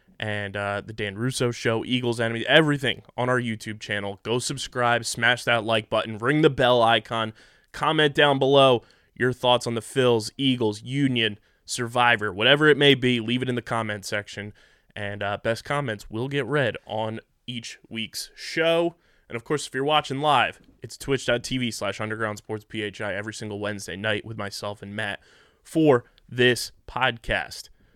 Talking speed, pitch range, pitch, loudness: 170 wpm, 110-130 Hz, 115 Hz, -24 LUFS